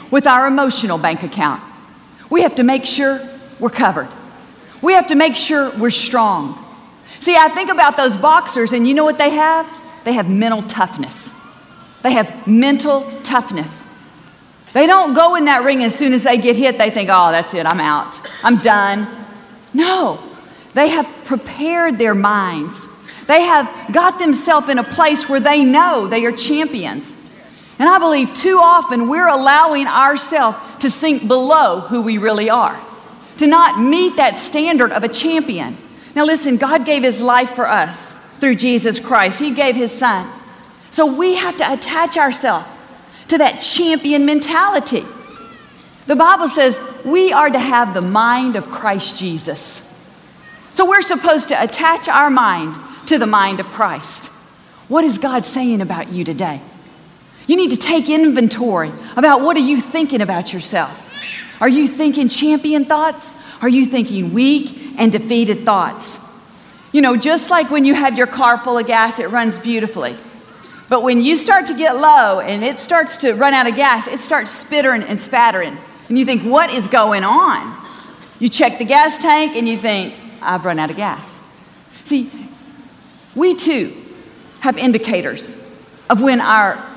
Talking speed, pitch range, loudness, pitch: 170 wpm, 230-305 Hz, -14 LUFS, 265 Hz